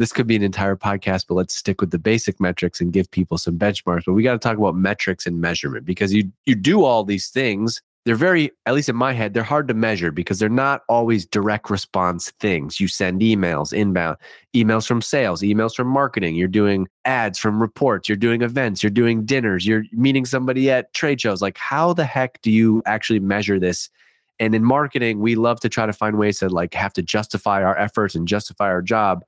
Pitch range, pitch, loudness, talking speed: 95-120 Hz, 105 Hz, -19 LUFS, 225 wpm